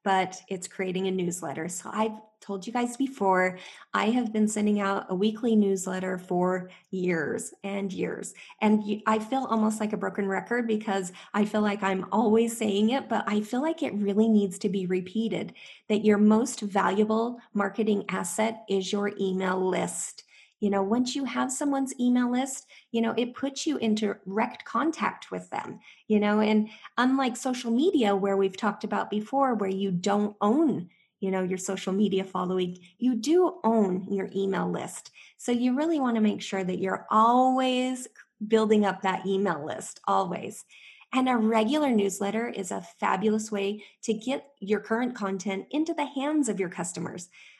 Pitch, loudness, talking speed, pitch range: 210 Hz, -27 LUFS, 175 wpm, 195-235 Hz